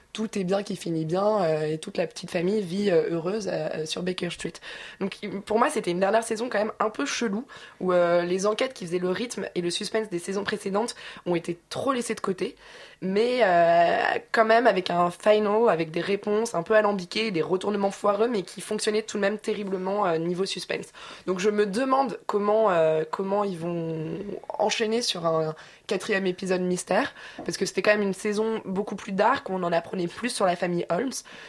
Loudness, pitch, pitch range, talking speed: -26 LUFS, 200 Hz, 175-215 Hz, 210 wpm